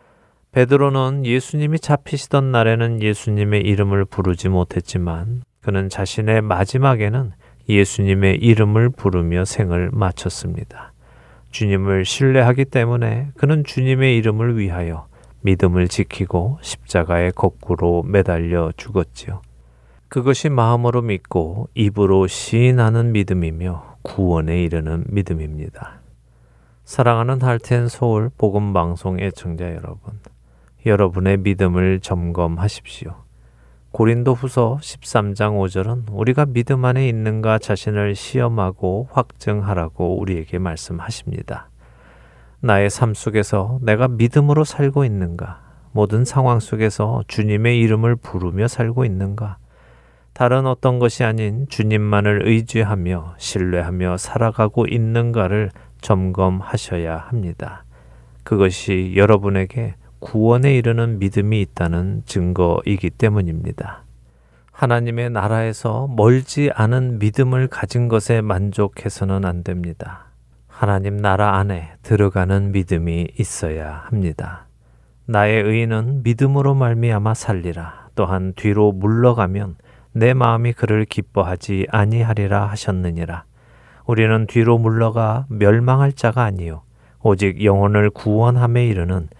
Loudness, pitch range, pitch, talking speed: -18 LUFS, 90-120 Hz, 105 Hz, 285 characters per minute